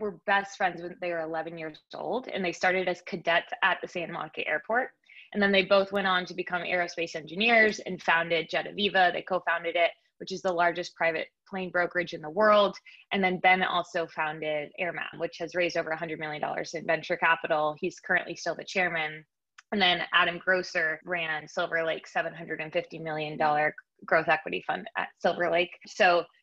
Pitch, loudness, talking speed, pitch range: 175 Hz, -28 LUFS, 190 wpm, 165-185 Hz